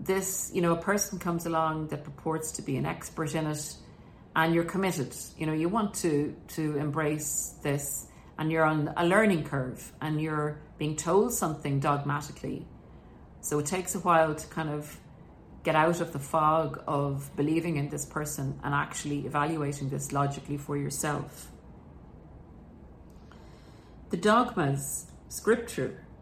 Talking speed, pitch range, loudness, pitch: 150 wpm, 140-165 Hz, -30 LUFS, 150 Hz